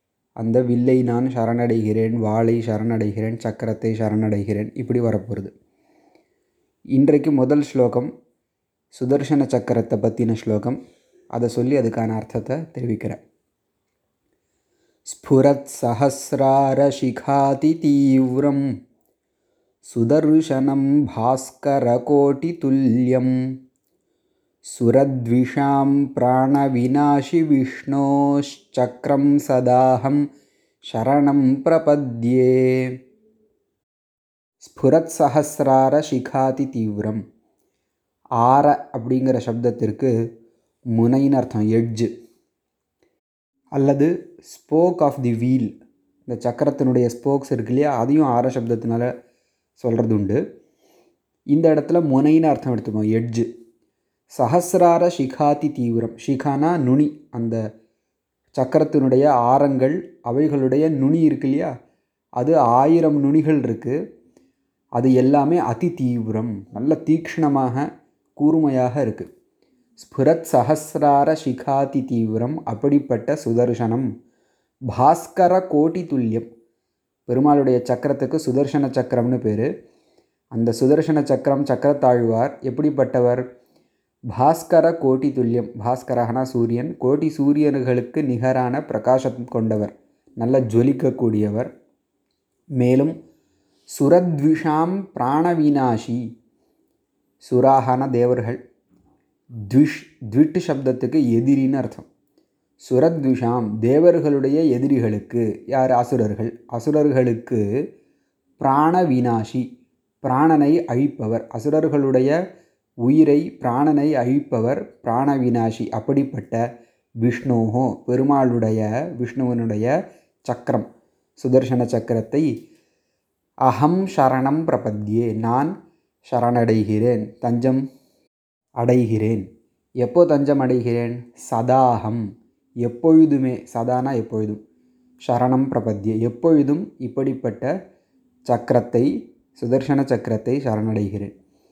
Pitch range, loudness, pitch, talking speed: 120-145 Hz, -19 LUFS, 130 Hz, 75 wpm